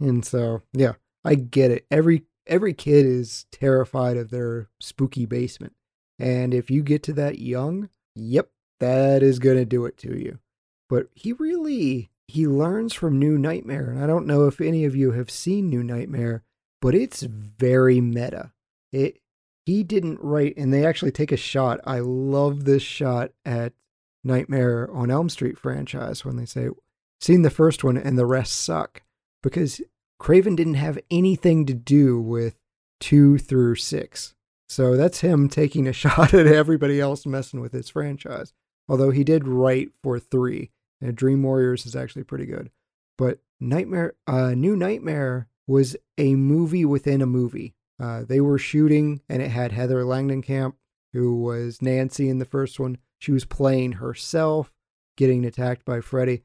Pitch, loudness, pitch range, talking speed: 135 Hz, -22 LUFS, 125-150 Hz, 170 wpm